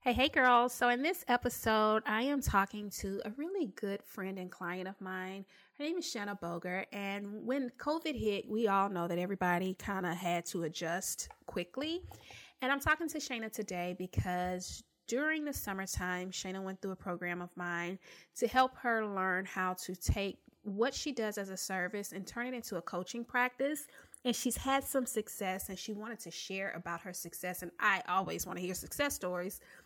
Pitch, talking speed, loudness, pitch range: 200 Hz, 195 wpm, -36 LUFS, 185-245 Hz